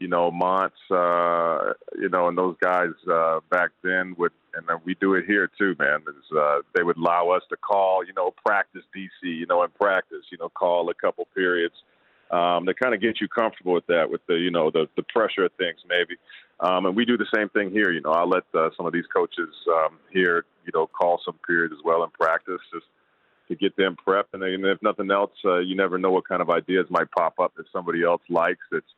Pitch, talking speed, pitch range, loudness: 90 Hz, 240 wpm, 85-95 Hz, -23 LUFS